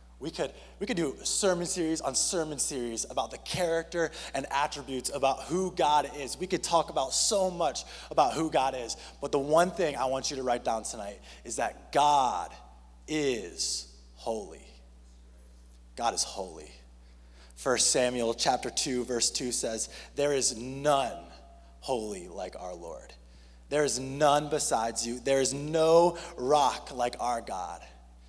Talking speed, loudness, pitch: 160 wpm, -29 LUFS, 130 Hz